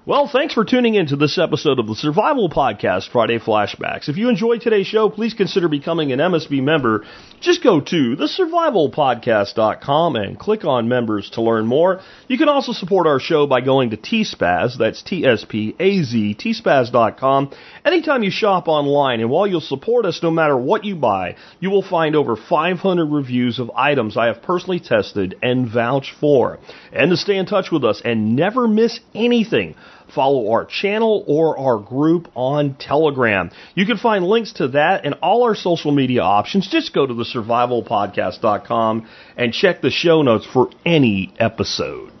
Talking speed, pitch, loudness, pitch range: 180 wpm, 155 Hz, -17 LUFS, 125-205 Hz